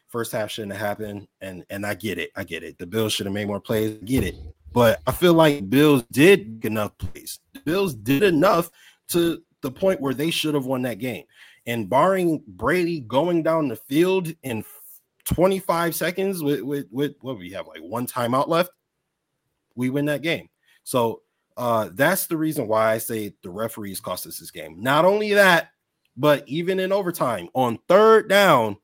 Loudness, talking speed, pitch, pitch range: -22 LUFS, 195 wpm, 140 Hz, 110-170 Hz